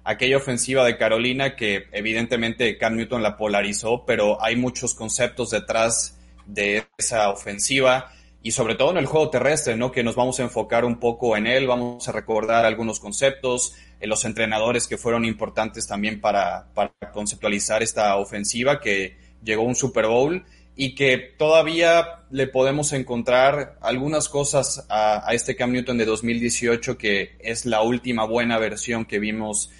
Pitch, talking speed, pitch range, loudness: 115 Hz, 160 wpm, 110-125 Hz, -22 LUFS